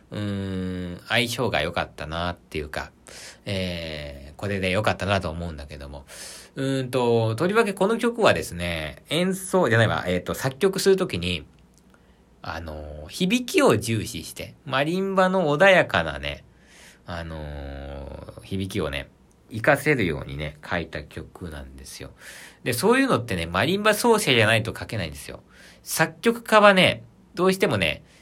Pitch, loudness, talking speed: 95 Hz, -23 LUFS, 320 characters per minute